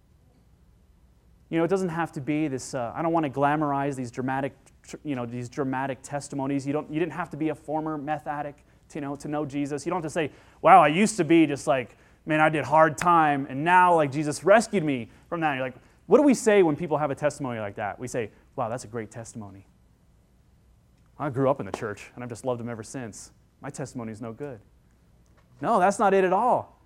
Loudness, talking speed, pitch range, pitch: -25 LUFS, 245 wpm, 130-160 Hz, 145 Hz